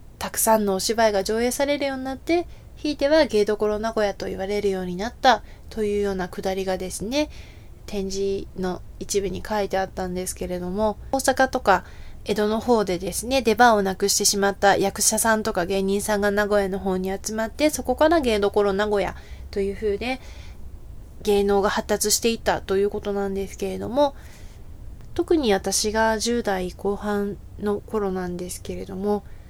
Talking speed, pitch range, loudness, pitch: 355 characters per minute, 195-225 Hz, -23 LUFS, 205 Hz